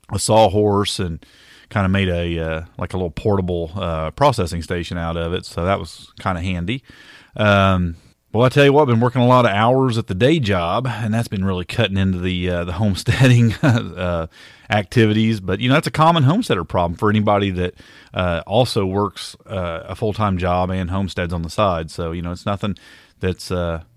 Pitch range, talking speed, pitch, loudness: 90-115 Hz, 210 wpm, 95 Hz, -19 LUFS